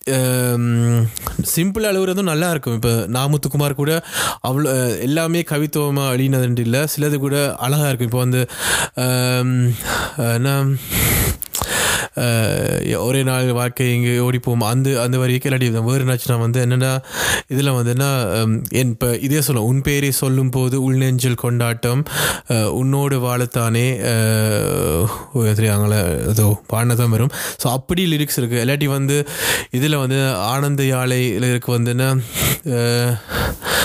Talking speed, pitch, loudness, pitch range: 110 wpm, 125 Hz, -18 LUFS, 120-140 Hz